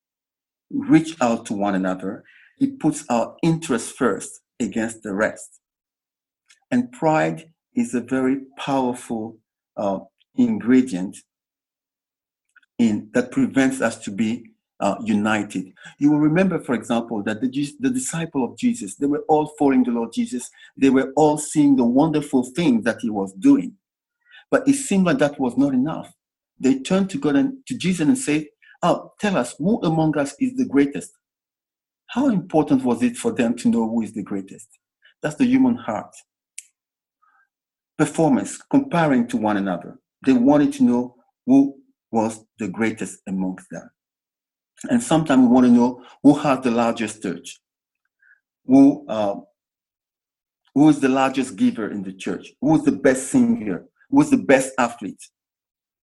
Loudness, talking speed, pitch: -20 LUFS, 155 wpm, 155 Hz